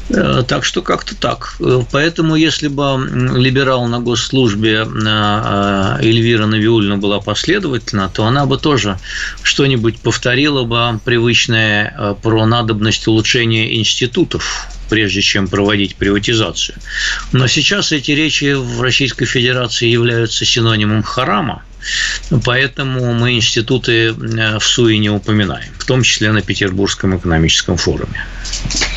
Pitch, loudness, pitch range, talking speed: 115 Hz, -13 LUFS, 105-125 Hz, 110 wpm